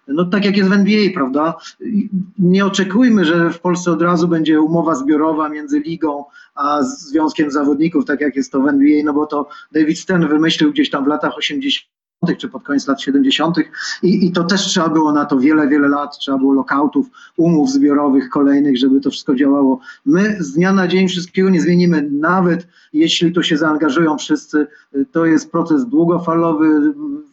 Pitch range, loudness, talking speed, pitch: 150-195 Hz, -15 LUFS, 180 wpm, 165 Hz